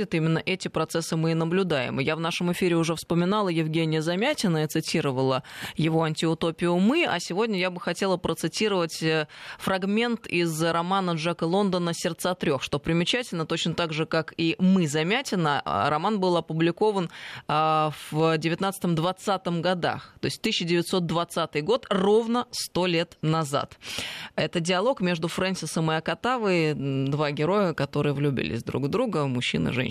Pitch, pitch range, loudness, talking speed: 170 Hz, 160-185 Hz, -25 LUFS, 140 wpm